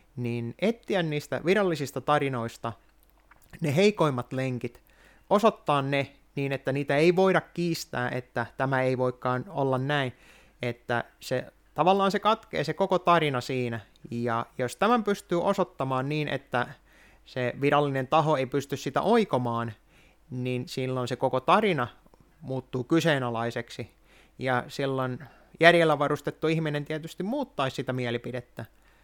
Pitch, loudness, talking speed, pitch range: 135 Hz, -27 LUFS, 125 wpm, 125-160 Hz